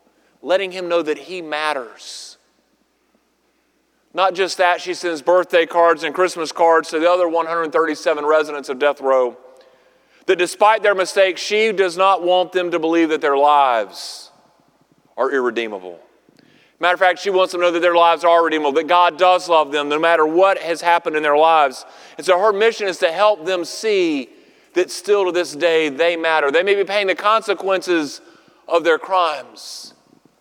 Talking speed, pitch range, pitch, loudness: 180 wpm, 165-195 Hz, 175 Hz, -17 LUFS